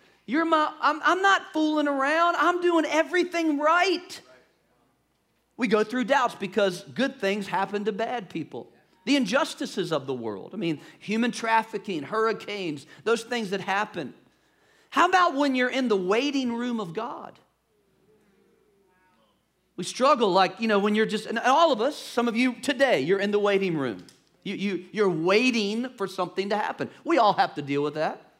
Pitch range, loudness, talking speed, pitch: 195-285 Hz, -25 LUFS, 175 wpm, 225 Hz